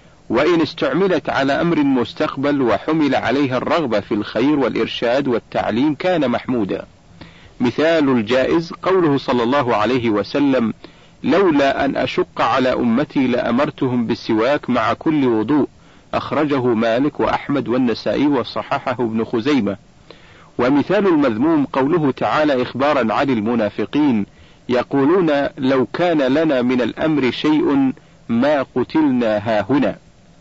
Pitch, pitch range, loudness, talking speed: 140 Hz, 125-180 Hz, -18 LUFS, 110 wpm